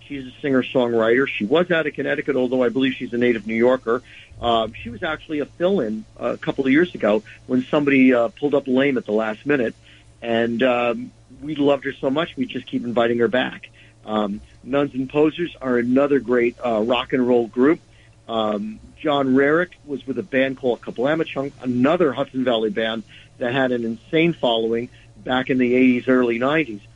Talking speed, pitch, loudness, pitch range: 195 wpm, 125 Hz, -21 LUFS, 115-140 Hz